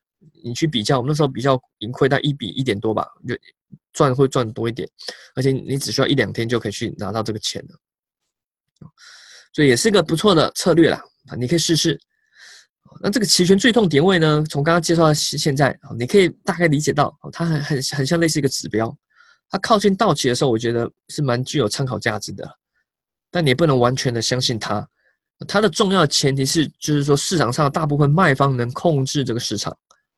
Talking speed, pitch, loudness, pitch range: 315 characters per minute, 145 Hz, -19 LUFS, 125-165 Hz